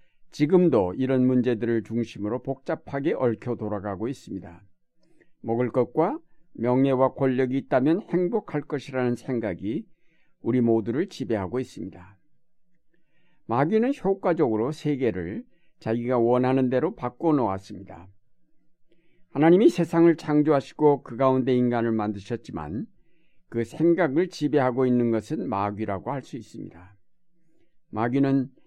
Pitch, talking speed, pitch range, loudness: 130 Hz, 290 characters per minute, 115-160 Hz, -25 LUFS